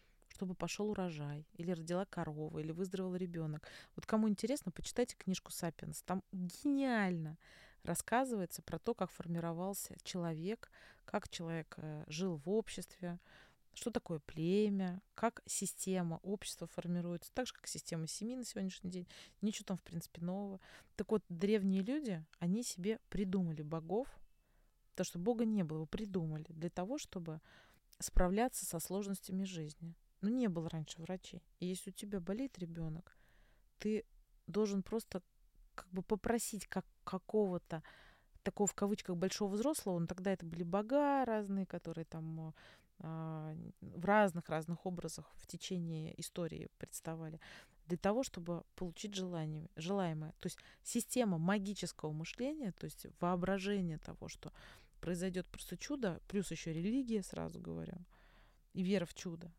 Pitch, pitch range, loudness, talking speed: 185 Hz, 165-205 Hz, -41 LUFS, 140 wpm